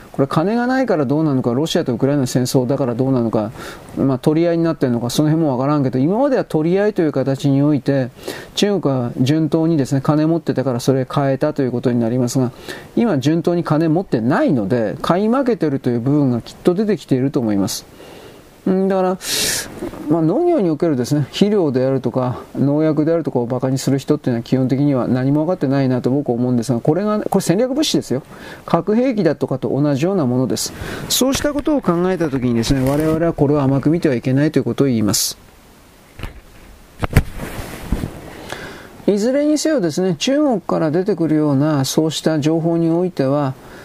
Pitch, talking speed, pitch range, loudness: 150 Hz, 420 characters per minute, 130-170 Hz, -17 LUFS